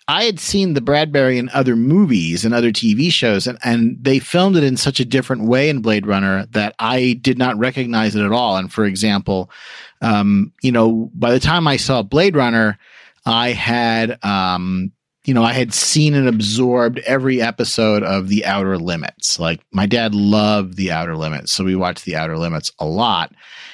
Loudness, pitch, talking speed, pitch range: -16 LUFS, 115 Hz, 195 wpm, 100-130 Hz